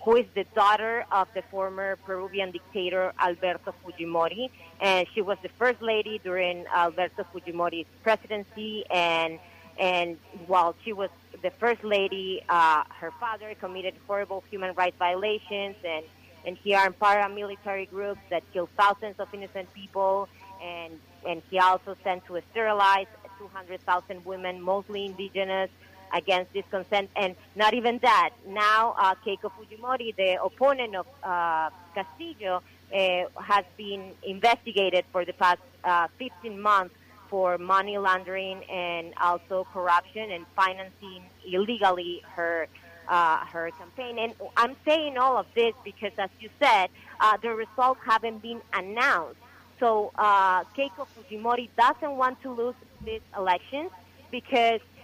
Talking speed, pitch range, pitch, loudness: 140 wpm, 180-215 Hz, 195 Hz, -27 LUFS